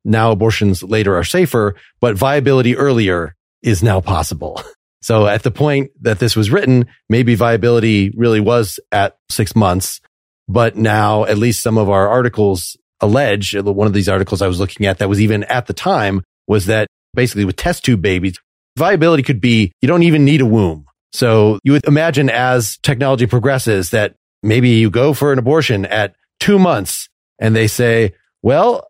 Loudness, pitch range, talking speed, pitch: -14 LUFS, 100-125 Hz, 180 wpm, 110 Hz